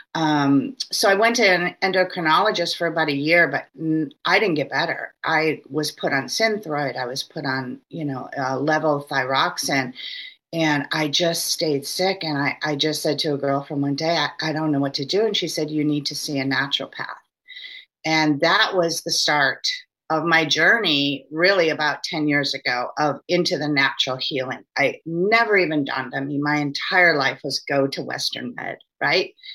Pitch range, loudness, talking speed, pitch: 140-175 Hz, -21 LUFS, 195 wpm, 155 Hz